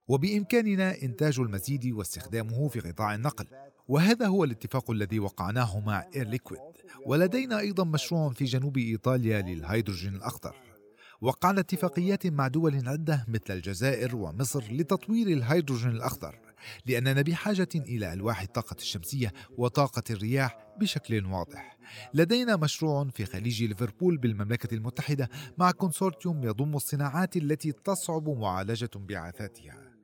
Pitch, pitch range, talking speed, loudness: 130 Hz, 110-160 Hz, 115 wpm, -29 LUFS